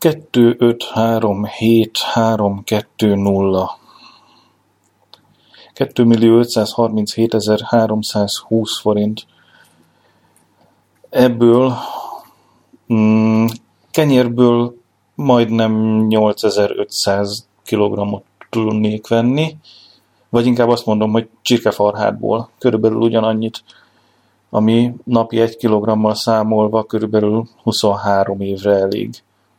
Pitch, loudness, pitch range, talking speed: 110 Hz, -15 LUFS, 105-115 Hz, 55 wpm